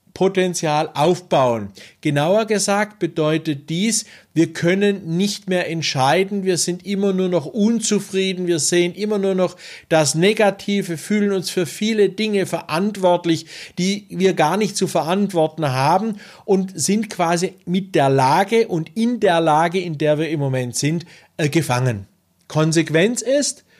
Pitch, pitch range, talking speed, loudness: 180 Hz, 160-200 Hz, 140 wpm, -19 LUFS